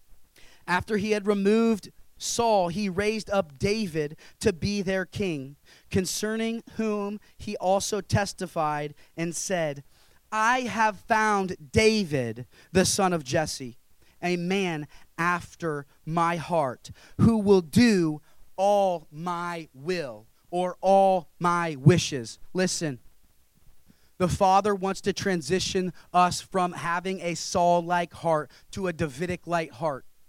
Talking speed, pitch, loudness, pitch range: 115 wpm, 180 Hz, -26 LUFS, 160-200 Hz